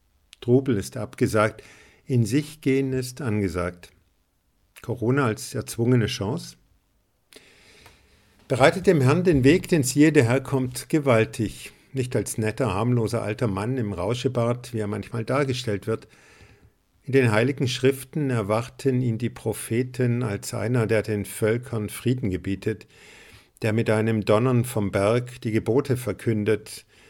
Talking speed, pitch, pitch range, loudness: 130 wpm, 115 Hz, 105-130 Hz, -24 LUFS